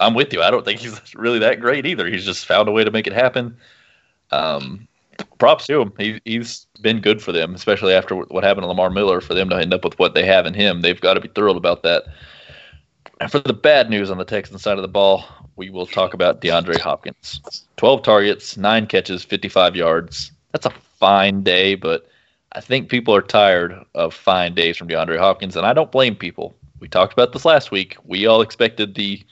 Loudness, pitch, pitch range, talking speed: -17 LUFS, 100 Hz, 90-110 Hz, 225 wpm